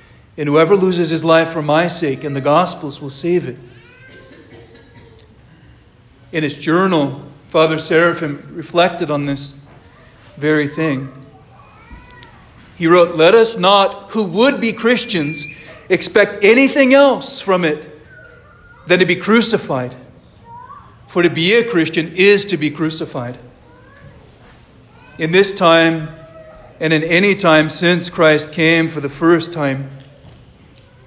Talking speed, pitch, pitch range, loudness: 125 wpm, 160 Hz, 140-180 Hz, -14 LUFS